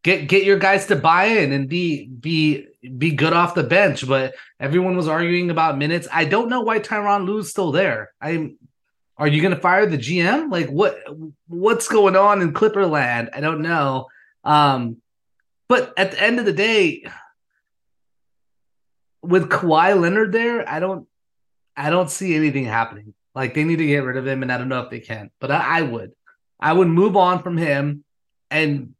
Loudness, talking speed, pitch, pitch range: -18 LUFS, 190 wpm, 165 Hz, 140-190 Hz